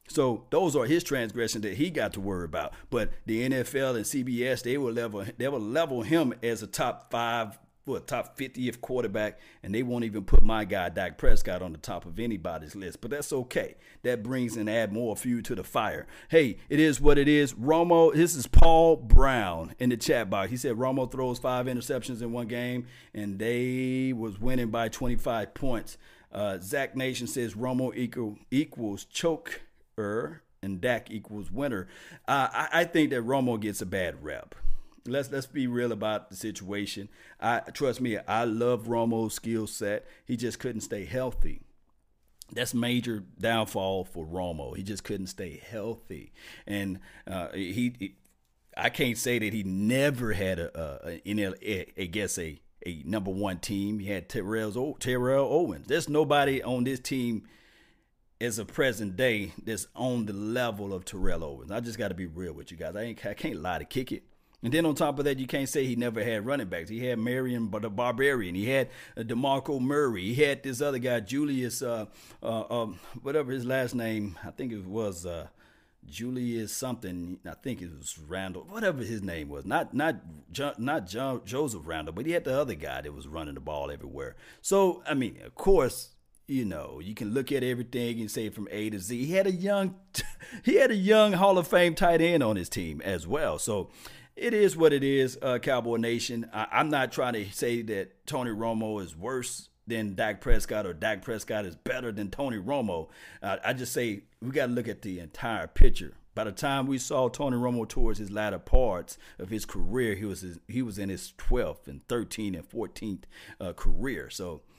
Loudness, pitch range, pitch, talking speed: -30 LUFS, 105-130 Hz, 115 Hz, 200 wpm